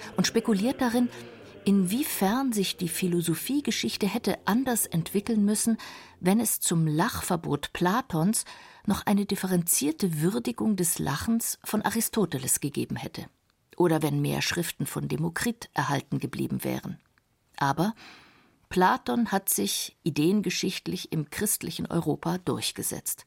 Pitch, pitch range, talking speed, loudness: 190 Hz, 165-220 Hz, 115 wpm, -27 LUFS